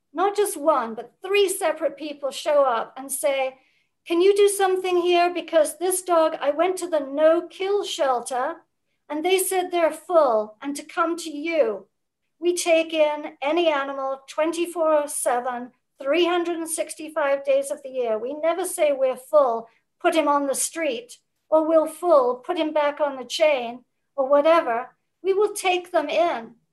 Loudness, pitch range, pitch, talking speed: -22 LUFS, 275-340 Hz, 310 Hz, 165 wpm